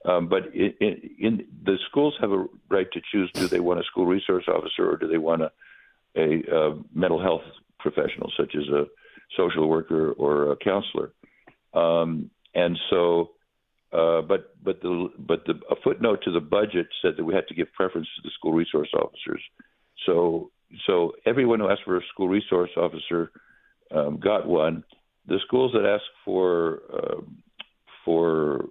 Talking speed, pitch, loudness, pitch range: 175 wpm, 85 Hz, -25 LUFS, 80-105 Hz